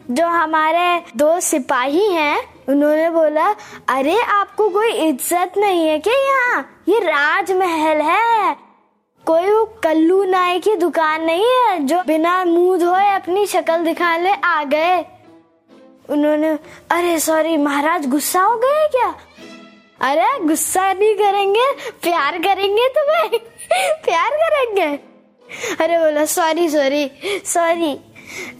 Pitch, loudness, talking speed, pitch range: 340 Hz, -16 LUFS, 120 wpm, 310-390 Hz